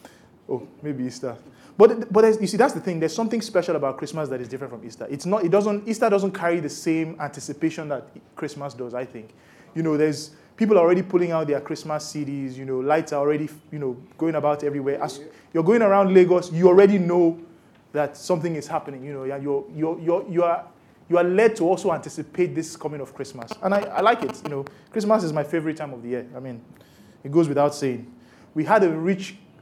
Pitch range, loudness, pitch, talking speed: 140-180 Hz, -22 LUFS, 160 Hz, 225 wpm